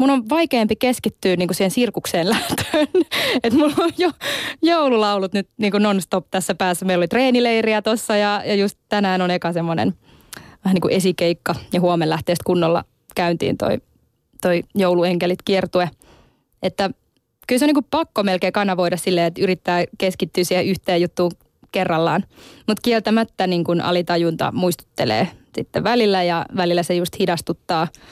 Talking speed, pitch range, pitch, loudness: 145 wpm, 175-220 Hz, 190 Hz, -19 LUFS